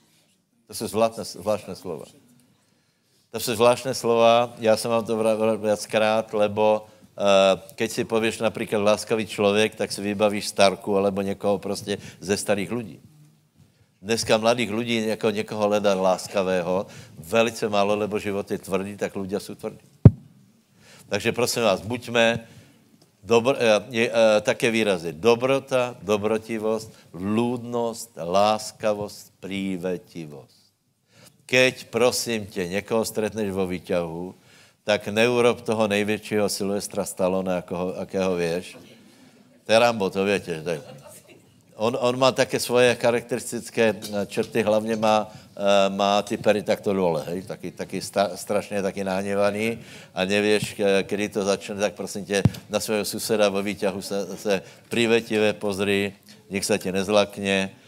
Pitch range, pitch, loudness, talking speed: 100-115 Hz, 105 Hz, -23 LUFS, 125 wpm